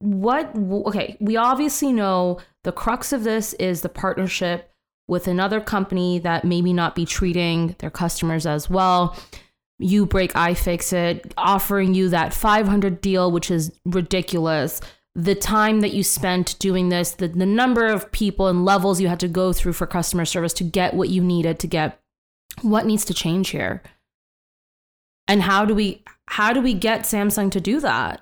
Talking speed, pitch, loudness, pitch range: 175 wpm, 185 Hz, -21 LUFS, 175-205 Hz